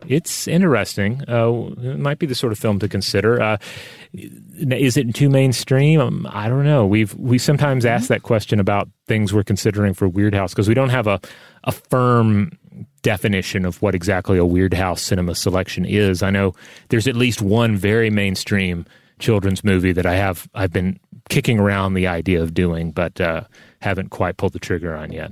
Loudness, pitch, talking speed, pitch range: -18 LUFS, 105 Hz, 190 wpm, 95-125 Hz